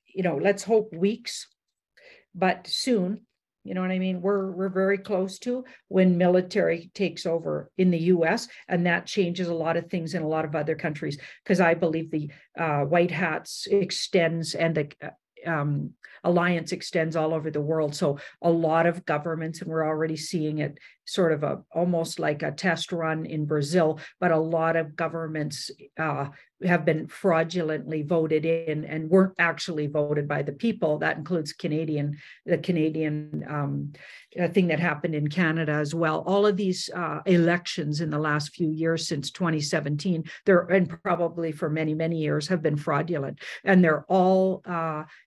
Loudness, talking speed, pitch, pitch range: -26 LUFS, 175 wpm, 165 Hz, 155-180 Hz